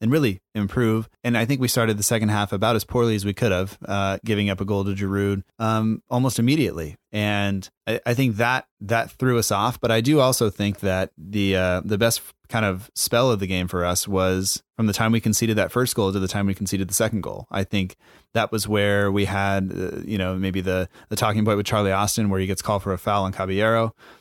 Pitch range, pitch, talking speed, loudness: 95-115 Hz, 105 Hz, 245 wpm, -22 LUFS